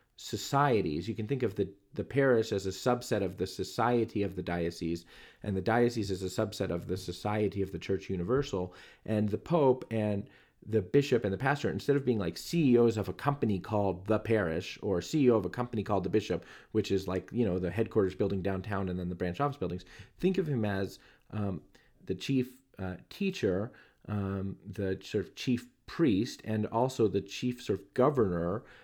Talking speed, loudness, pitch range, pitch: 200 wpm, -32 LUFS, 95-120 Hz, 105 Hz